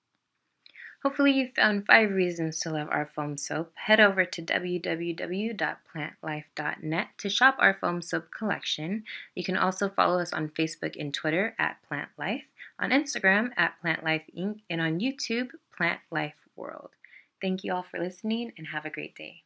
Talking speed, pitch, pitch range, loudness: 165 wpm, 180 Hz, 160-215 Hz, -28 LUFS